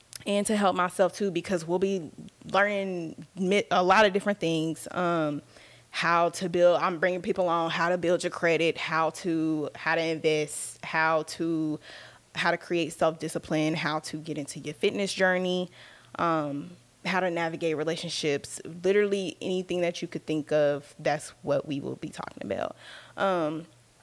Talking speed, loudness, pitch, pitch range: 160 wpm, -28 LUFS, 170 Hz, 155-185 Hz